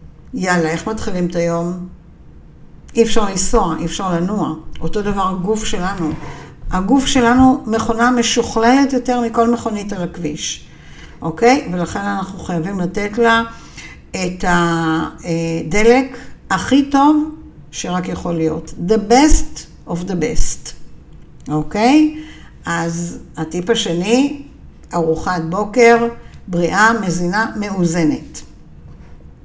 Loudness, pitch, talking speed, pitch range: -16 LUFS, 190 Hz, 105 wpm, 170-235 Hz